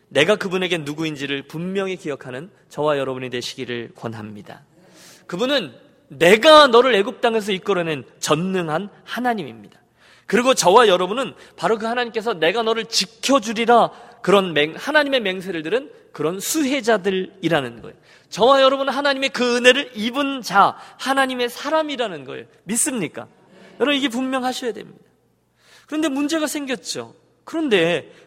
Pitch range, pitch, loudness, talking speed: 170-265 Hz, 225 Hz, -19 LUFS, 350 characters per minute